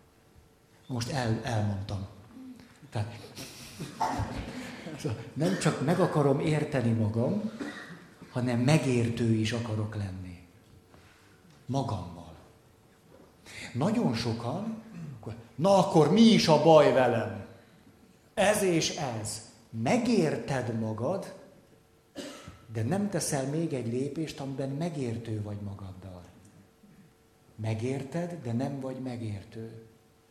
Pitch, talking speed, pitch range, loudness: 125 Hz, 90 wpm, 110-160 Hz, -29 LUFS